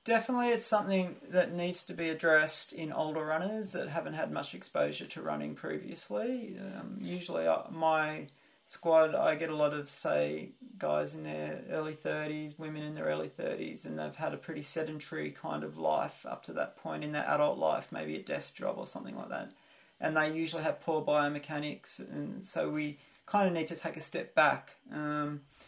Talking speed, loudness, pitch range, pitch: 195 wpm, -34 LUFS, 105-170 Hz, 155 Hz